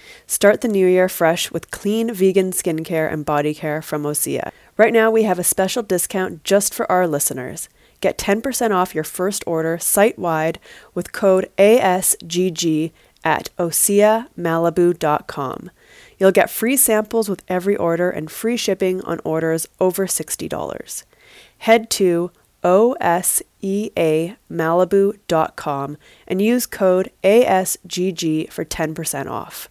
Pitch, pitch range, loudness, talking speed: 185 Hz, 165-205 Hz, -18 LUFS, 125 wpm